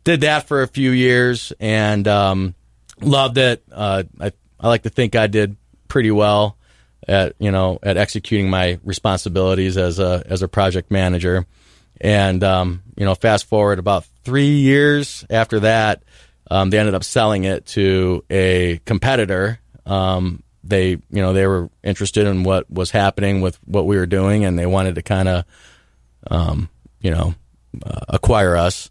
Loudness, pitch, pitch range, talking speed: -17 LUFS, 95 Hz, 90-105 Hz, 165 wpm